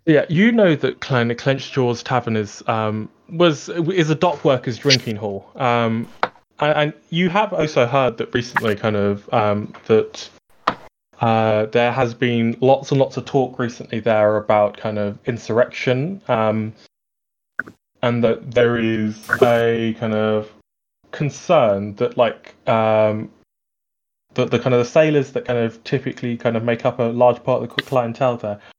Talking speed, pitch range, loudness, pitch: 165 wpm, 110-135 Hz, -19 LUFS, 120 Hz